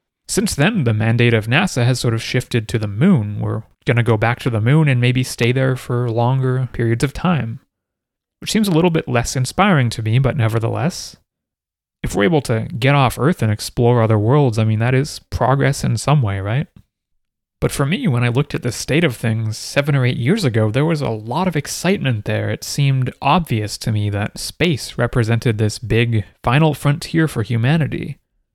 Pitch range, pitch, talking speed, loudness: 115-145 Hz, 125 Hz, 205 wpm, -17 LUFS